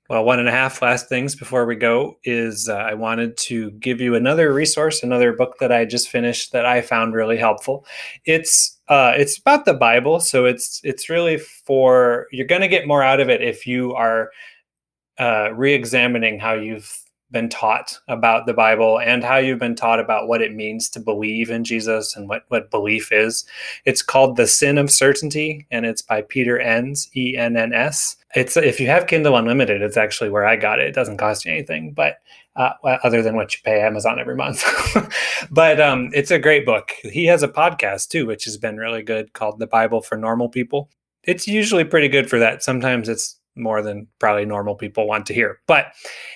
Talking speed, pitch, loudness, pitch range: 210 wpm, 120 Hz, -18 LUFS, 110-135 Hz